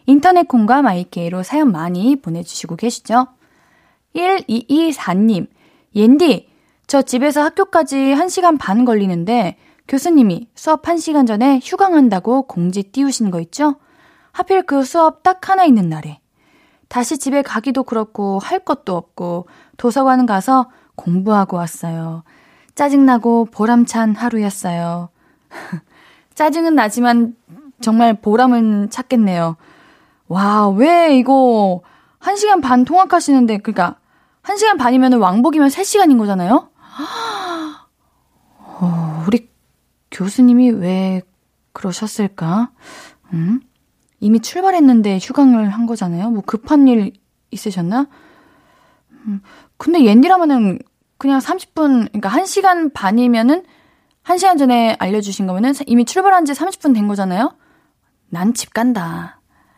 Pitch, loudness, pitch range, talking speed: 245 Hz, -15 LUFS, 205-315 Hz, 250 characters per minute